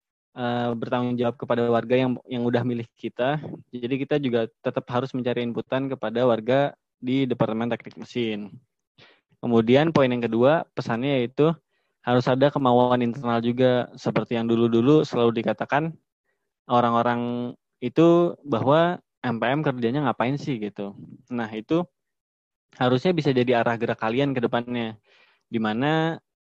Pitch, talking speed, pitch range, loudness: 125 Hz, 130 wpm, 115-135 Hz, -24 LUFS